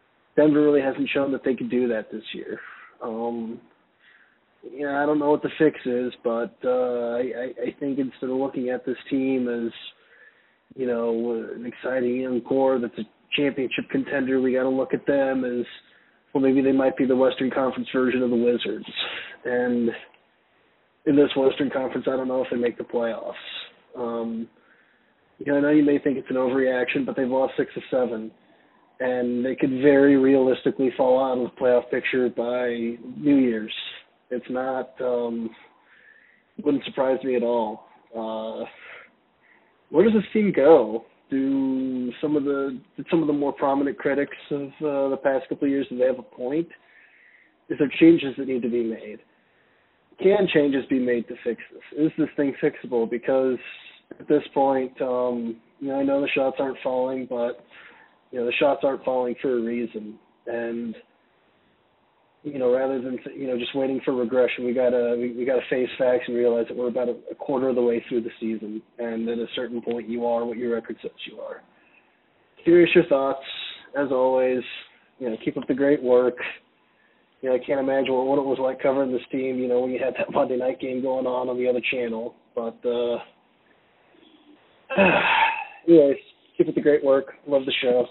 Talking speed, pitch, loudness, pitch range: 190 wpm, 130 Hz, -24 LUFS, 120-140 Hz